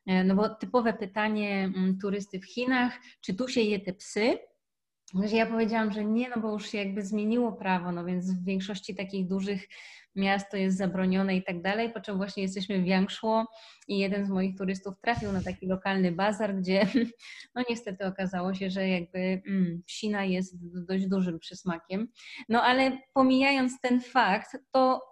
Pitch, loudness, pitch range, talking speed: 200 Hz, -29 LUFS, 190-225 Hz, 165 wpm